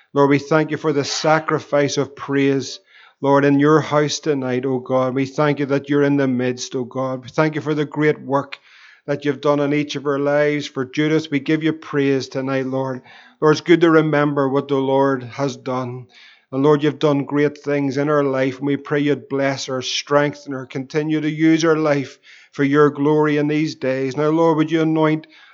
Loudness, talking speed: -19 LUFS, 220 wpm